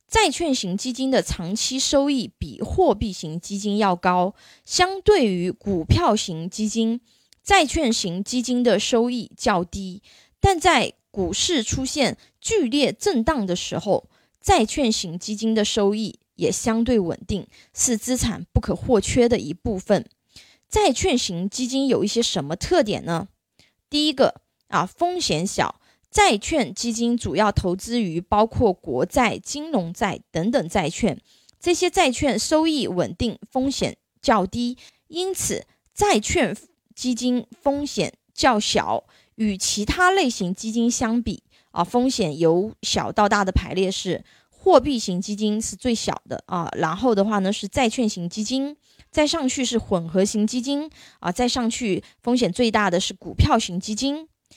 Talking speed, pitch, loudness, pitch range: 220 characters per minute, 230 Hz, -22 LUFS, 200-265 Hz